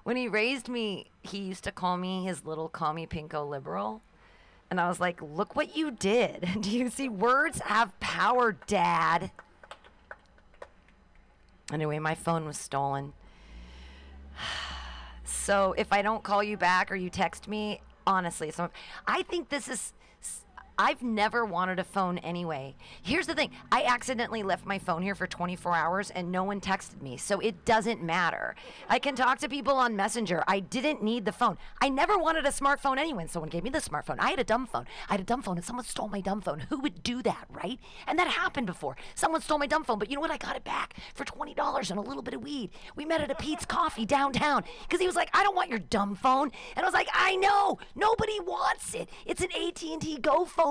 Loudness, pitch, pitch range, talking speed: -30 LUFS, 215 Hz, 175-280 Hz, 210 wpm